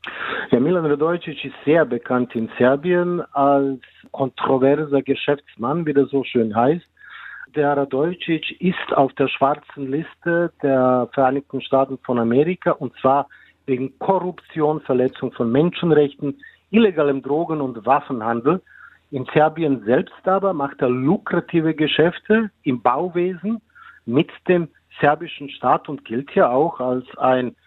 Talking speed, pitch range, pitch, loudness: 130 wpm, 130-165 Hz, 145 Hz, -20 LUFS